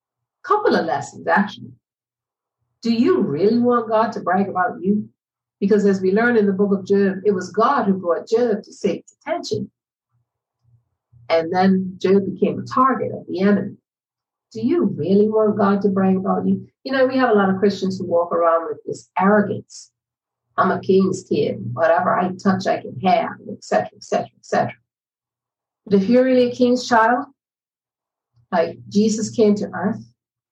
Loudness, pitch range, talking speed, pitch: -19 LUFS, 185-225 Hz, 175 wpm, 200 Hz